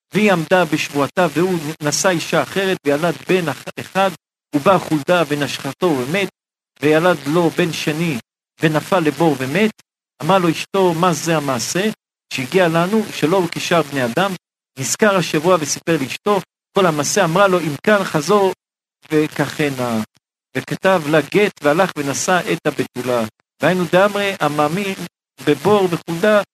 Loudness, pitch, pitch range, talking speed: -17 LUFS, 165 Hz, 150-190 Hz, 130 wpm